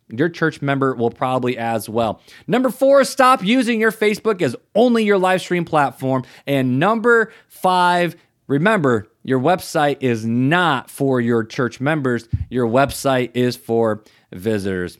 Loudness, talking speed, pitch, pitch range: -18 LUFS, 145 wpm, 135 Hz, 120-185 Hz